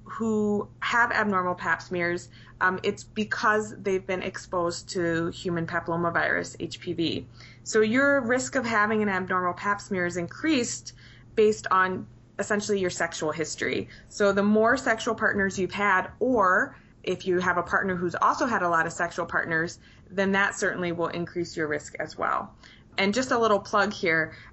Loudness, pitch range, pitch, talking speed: -26 LUFS, 170-210 Hz, 185 Hz, 165 wpm